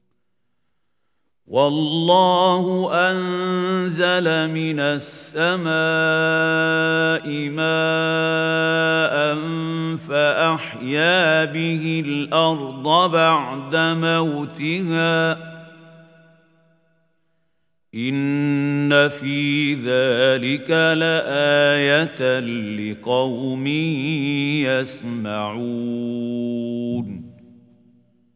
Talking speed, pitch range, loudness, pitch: 35 wpm, 135-165 Hz, -19 LUFS, 160 Hz